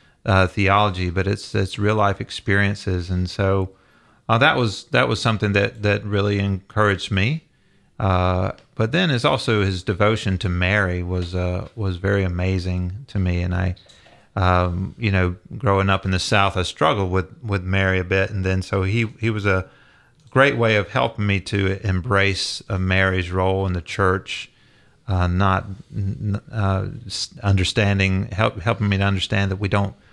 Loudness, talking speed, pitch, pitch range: -21 LUFS, 170 wpm, 100 Hz, 95-105 Hz